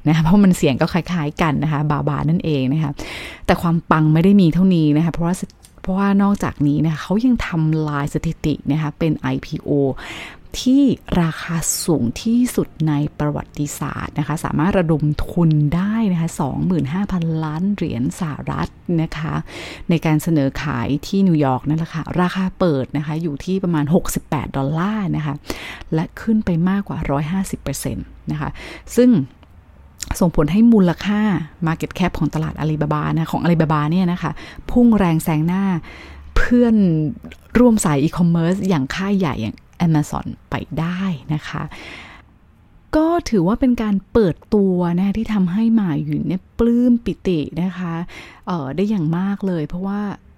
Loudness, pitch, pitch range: -19 LUFS, 165 Hz, 150-190 Hz